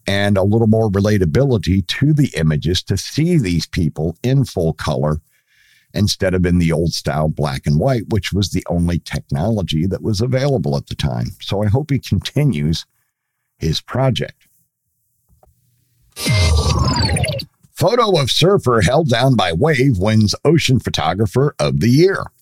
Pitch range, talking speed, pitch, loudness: 85-130 Hz, 145 wpm, 105 Hz, -17 LUFS